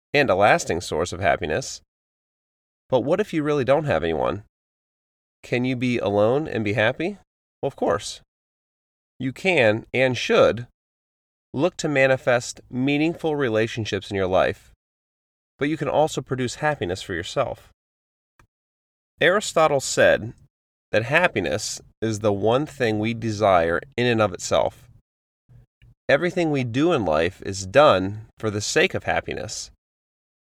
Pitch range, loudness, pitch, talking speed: 95-135 Hz, -22 LUFS, 115 Hz, 140 wpm